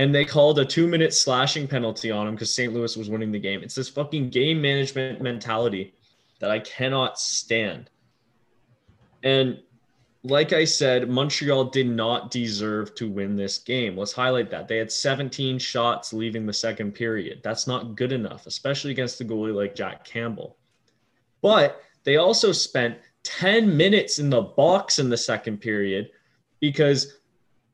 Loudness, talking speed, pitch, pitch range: -23 LUFS, 160 wpm, 125 Hz, 110-135 Hz